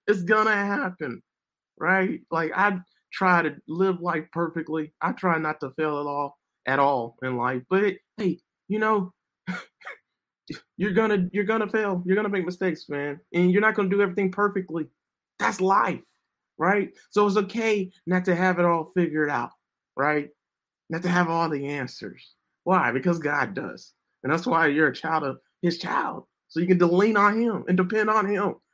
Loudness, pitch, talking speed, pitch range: -25 LUFS, 180 Hz, 180 wpm, 155-200 Hz